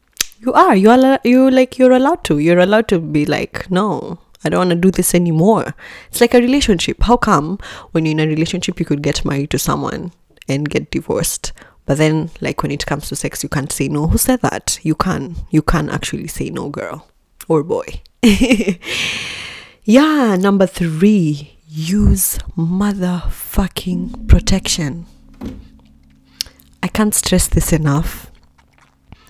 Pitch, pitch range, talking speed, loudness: 175 Hz, 150-210 Hz, 160 wpm, -15 LUFS